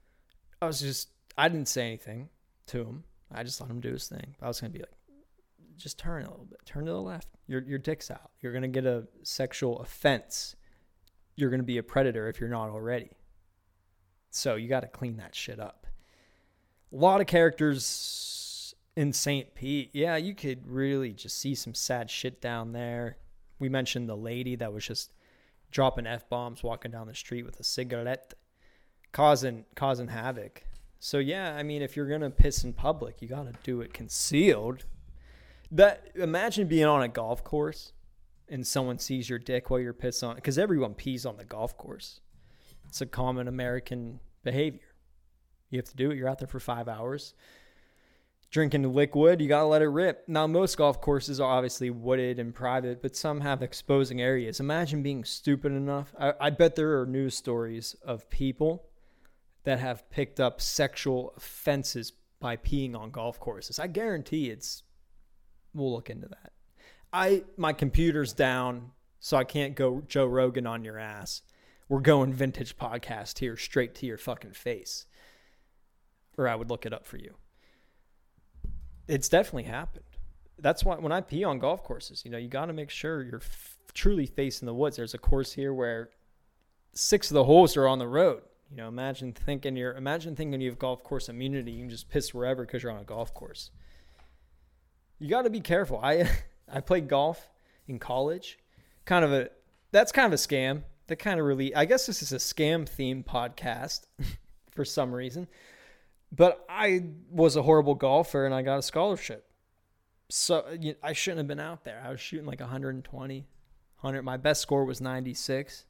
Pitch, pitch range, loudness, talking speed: 130 Hz, 115-145 Hz, -29 LUFS, 185 wpm